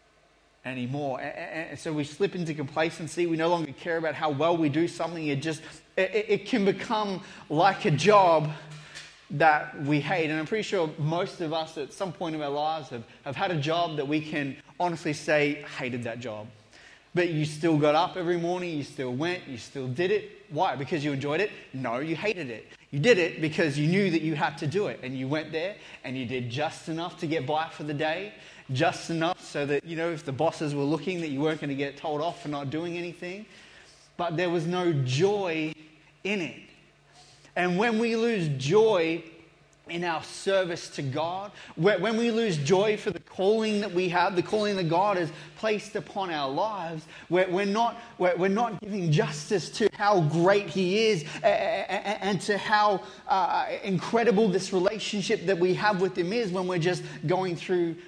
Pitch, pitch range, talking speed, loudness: 170 Hz, 155-195 Hz, 200 wpm, -27 LUFS